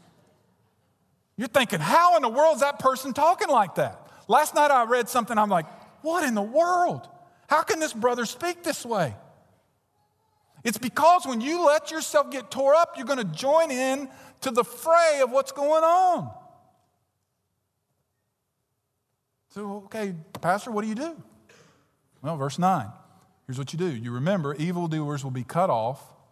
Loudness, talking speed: -24 LUFS, 165 wpm